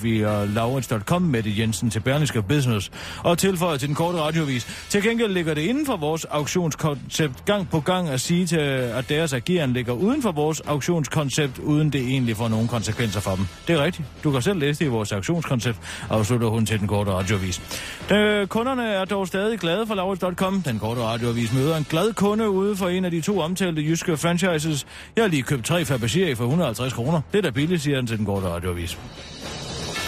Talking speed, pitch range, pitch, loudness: 210 wpm, 115-180 Hz, 150 Hz, -23 LUFS